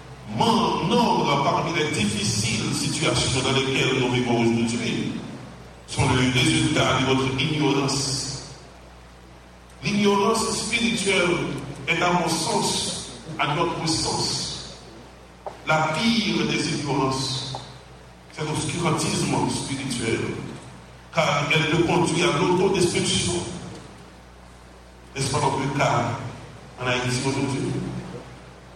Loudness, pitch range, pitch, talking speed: -23 LUFS, 115-160 Hz, 135 Hz, 95 wpm